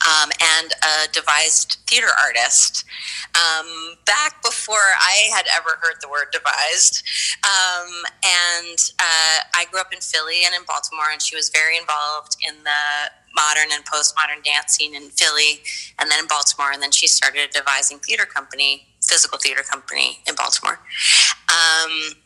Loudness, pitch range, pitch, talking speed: -16 LUFS, 150-165 Hz, 155 Hz, 155 wpm